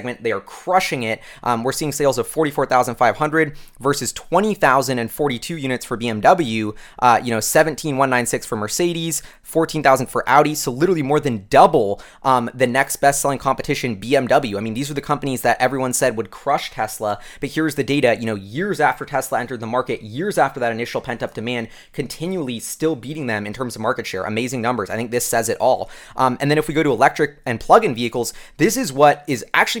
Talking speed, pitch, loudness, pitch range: 200 wpm, 130 Hz, -19 LUFS, 120-150 Hz